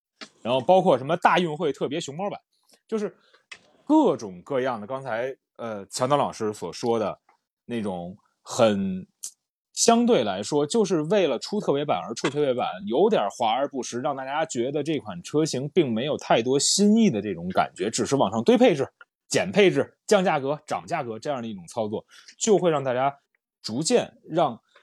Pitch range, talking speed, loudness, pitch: 125-200 Hz, 265 characters per minute, -24 LUFS, 150 Hz